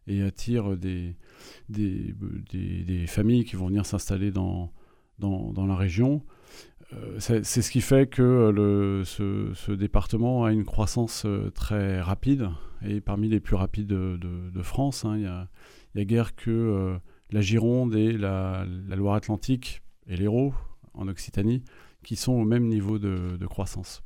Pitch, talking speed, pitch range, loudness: 100 Hz, 170 wpm, 95-115 Hz, -27 LUFS